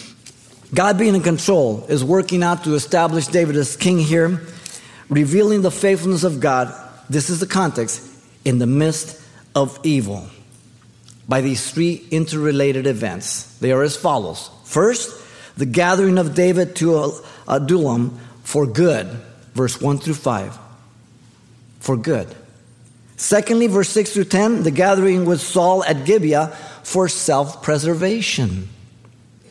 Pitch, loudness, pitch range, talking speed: 150 Hz, -18 LUFS, 120-180 Hz, 130 wpm